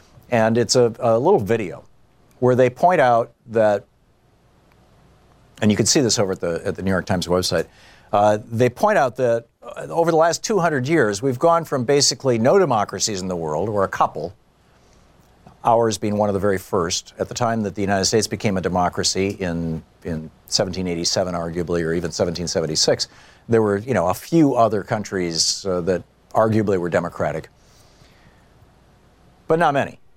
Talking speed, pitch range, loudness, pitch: 175 wpm, 90-120 Hz, -20 LUFS, 105 Hz